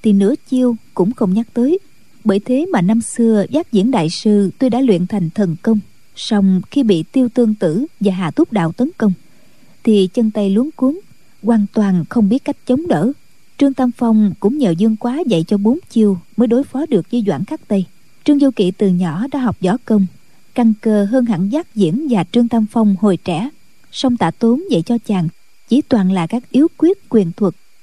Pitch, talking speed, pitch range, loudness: 220 Hz, 215 wpm, 195-250 Hz, -16 LUFS